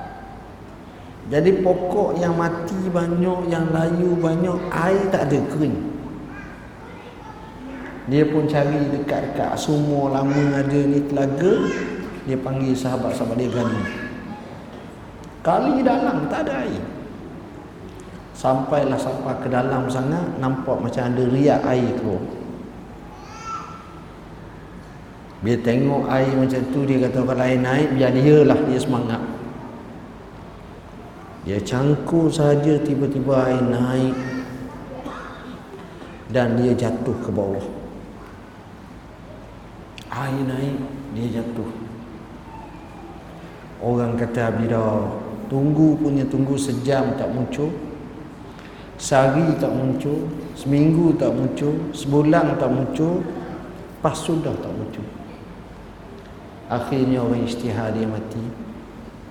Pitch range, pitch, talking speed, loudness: 115-145 Hz, 130 Hz, 100 wpm, -21 LUFS